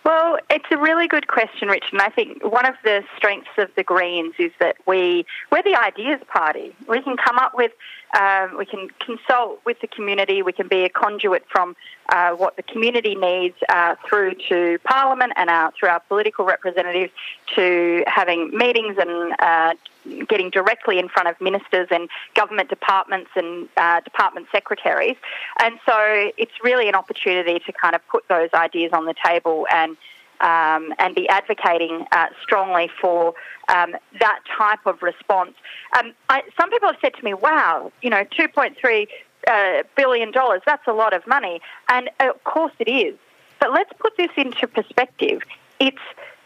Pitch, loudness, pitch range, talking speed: 210 Hz, -19 LUFS, 180-270 Hz, 175 wpm